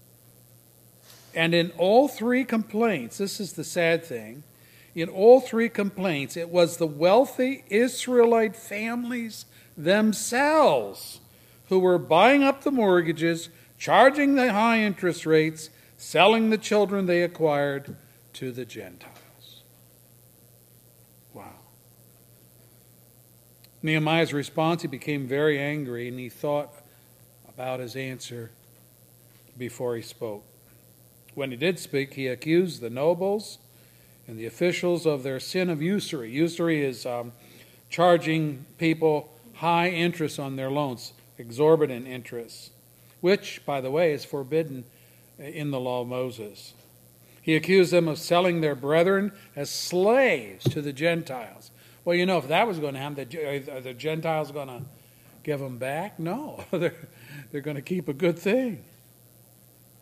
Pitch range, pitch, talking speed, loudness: 125-180 Hz, 155 Hz, 130 wpm, -24 LUFS